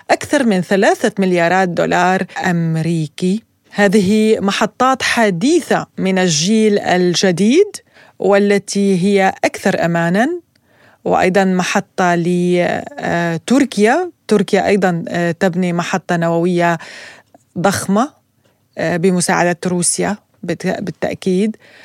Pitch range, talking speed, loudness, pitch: 175-210 Hz, 75 wpm, -15 LUFS, 190 Hz